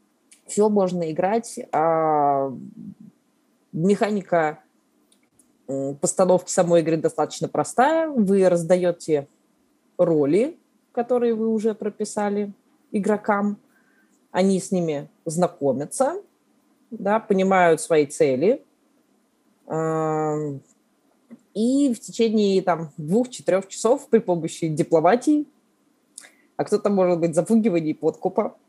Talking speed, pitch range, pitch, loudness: 85 wpm, 170-245 Hz, 205 Hz, -22 LUFS